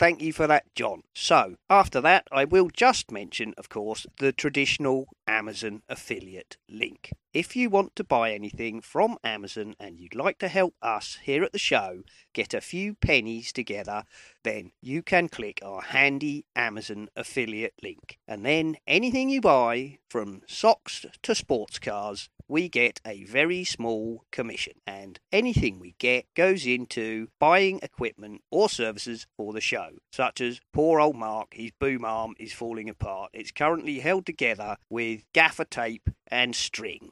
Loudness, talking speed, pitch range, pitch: -26 LUFS, 160 wpm, 110-160 Hz, 125 Hz